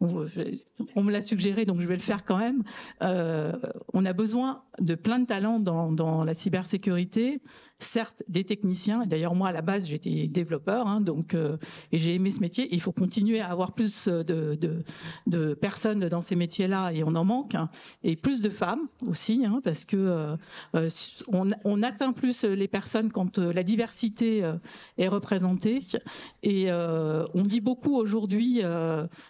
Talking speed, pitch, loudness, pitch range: 180 wpm, 195 Hz, -28 LUFS, 170-225 Hz